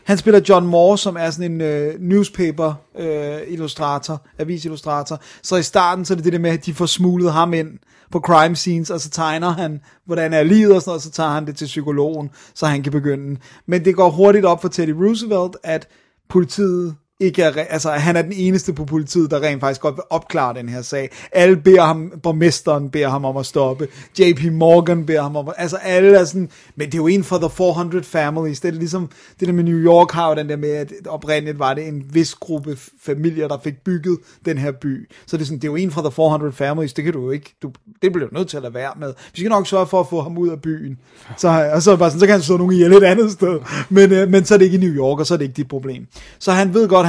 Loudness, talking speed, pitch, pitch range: -16 LUFS, 265 wpm, 165 Hz, 150-180 Hz